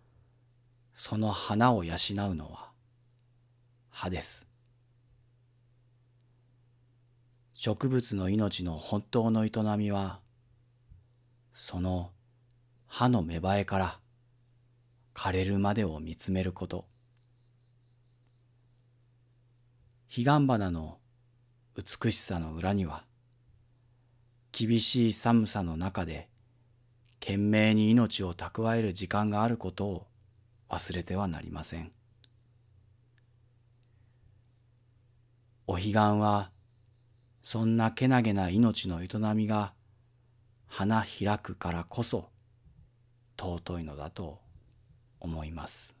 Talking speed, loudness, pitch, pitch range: 155 characters per minute, -30 LUFS, 115 Hz, 100-120 Hz